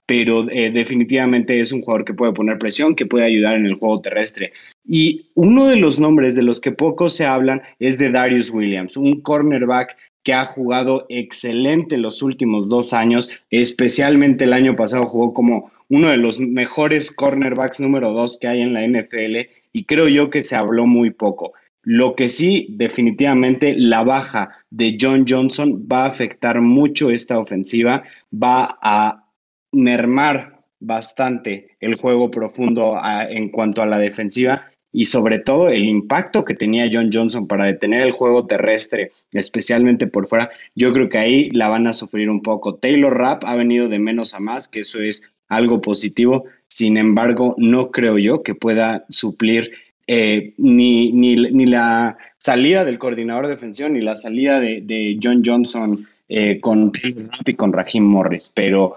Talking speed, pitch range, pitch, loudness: 175 wpm, 110-130 Hz, 120 Hz, -16 LUFS